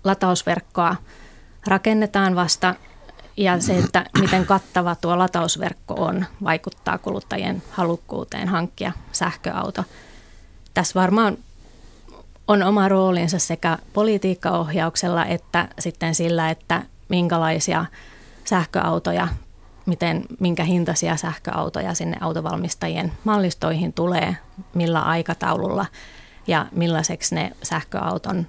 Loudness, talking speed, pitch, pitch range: -21 LUFS, 90 wpm, 175 Hz, 165-190 Hz